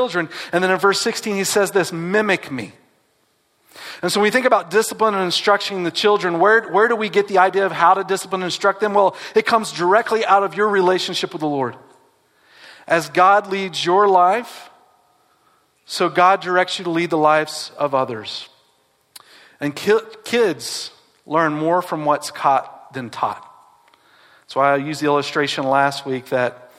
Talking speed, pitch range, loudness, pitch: 180 wpm, 155-205 Hz, -18 LUFS, 180 Hz